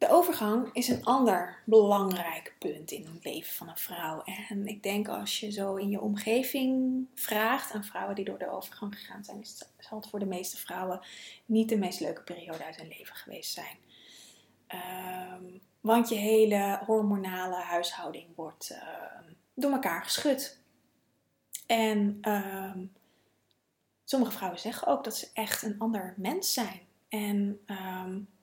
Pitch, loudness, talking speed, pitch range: 205 Hz, -31 LUFS, 155 wpm, 185-225 Hz